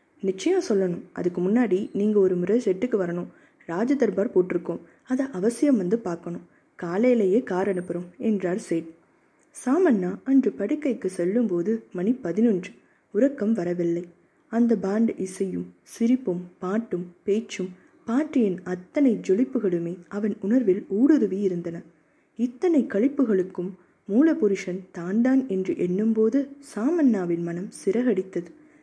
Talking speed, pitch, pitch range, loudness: 105 wpm, 200 Hz, 180-245 Hz, -25 LUFS